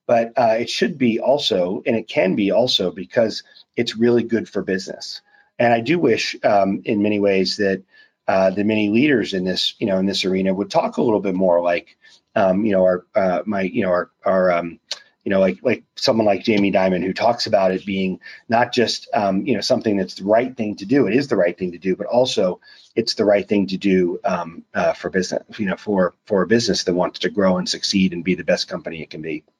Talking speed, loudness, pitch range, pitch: 240 wpm, -19 LUFS, 95-105 Hz, 95 Hz